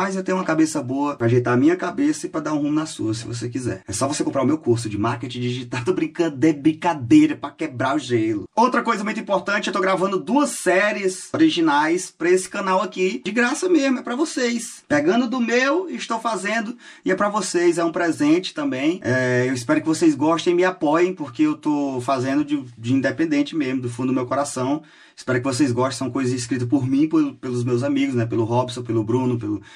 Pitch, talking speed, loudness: 175 Hz, 230 wpm, -21 LUFS